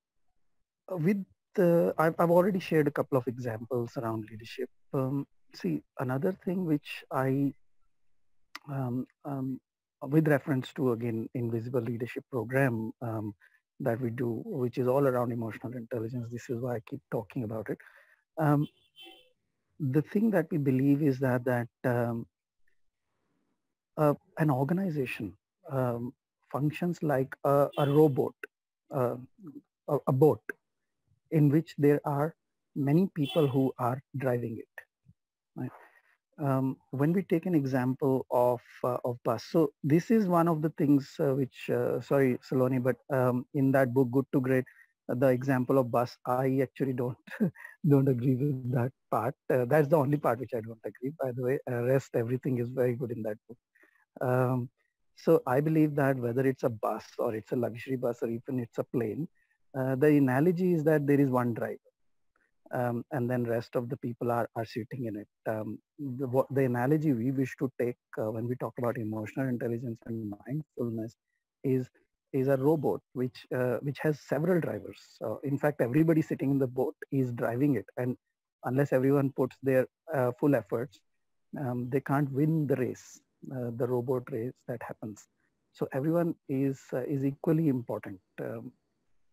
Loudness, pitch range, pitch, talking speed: -30 LUFS, 125-145 Hz, 135 Hz, 165 wpm